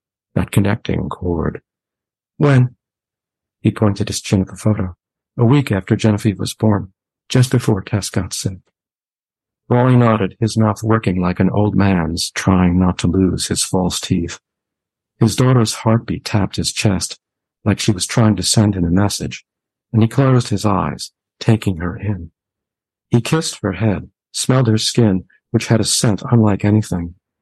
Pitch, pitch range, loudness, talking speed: 105 Hz, 95-115 Hz, -17 LUFS, 160 wpm